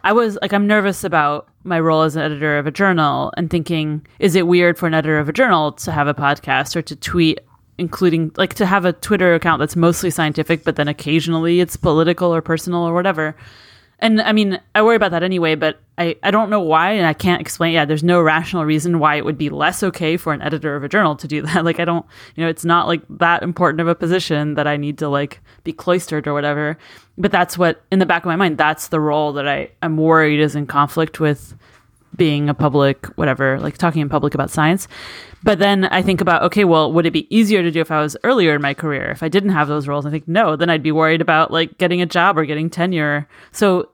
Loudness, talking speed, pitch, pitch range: -17 LUFS, 250 wpm, 165 Hz, 150-175 Hz